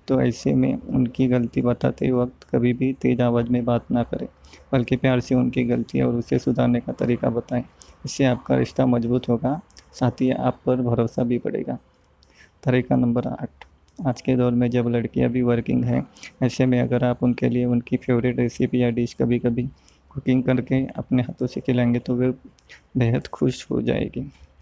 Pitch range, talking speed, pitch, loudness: 120-130 Hz, 185 wpm, 125 Hz, -22 LUFS